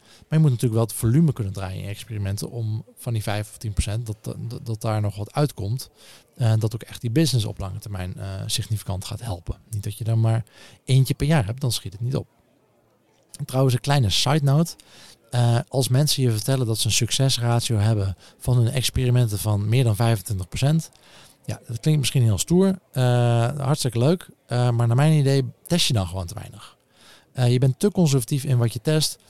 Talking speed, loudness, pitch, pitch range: 215 wpm, -23 LUFS, 120 Hz, 110-135 Hz